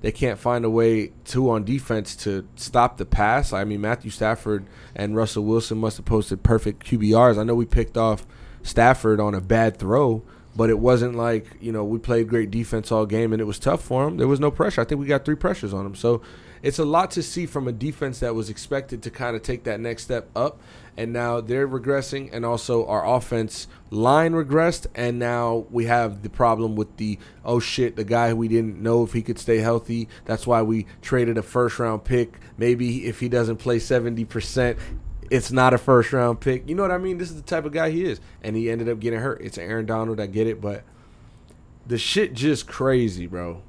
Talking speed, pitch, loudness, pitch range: 225 wpm, 115 Hz, -23 LUFS, 110-125 Hz